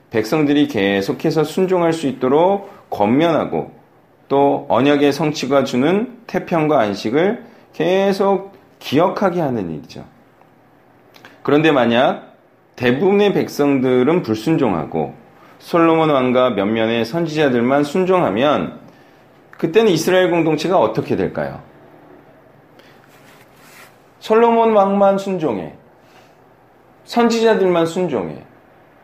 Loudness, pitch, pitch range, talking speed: -16 LUFS, 160 Hz, 135-190 Hz, 235 characters per minute